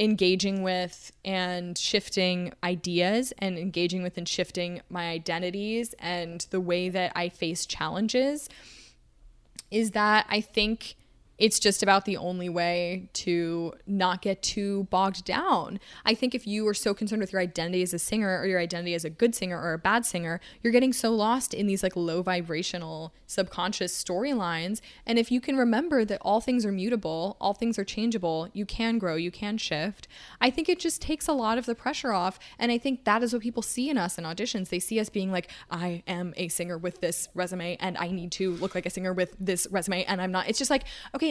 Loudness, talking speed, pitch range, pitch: -28 LUFS, 210 wpm, 175-220 Hz, 190 Hz